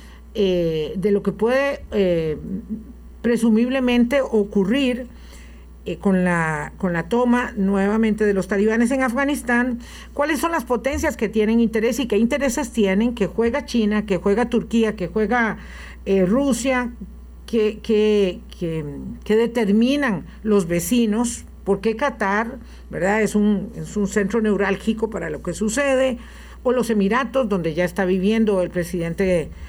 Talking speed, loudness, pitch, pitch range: 135 wpm, -20 LUFS, 215 Hz, 195-240 Hz